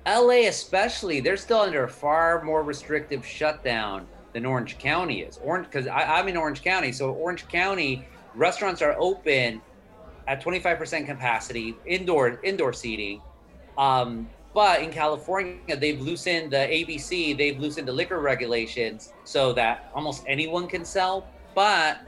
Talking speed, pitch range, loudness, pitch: 140 wpm, 130-175 Hz, -25 LUFS, 150 Hz